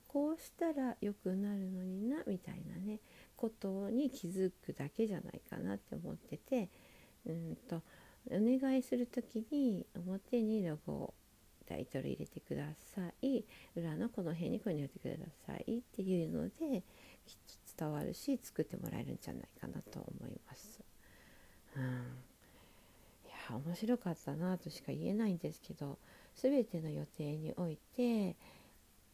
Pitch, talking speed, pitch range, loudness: 190 Hz, 290 characters per minute, 165-235 Hz, -41 LUFS